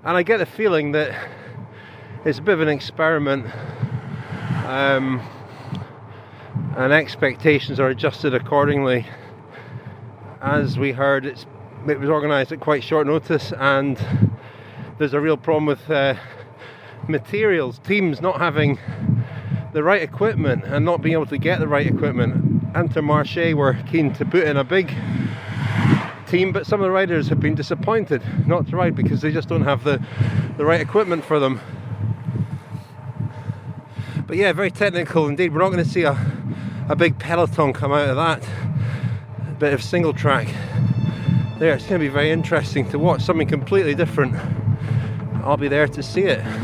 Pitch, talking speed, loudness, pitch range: 145 Hz, 160 wpm, -20 LUFS, 125-155 Hz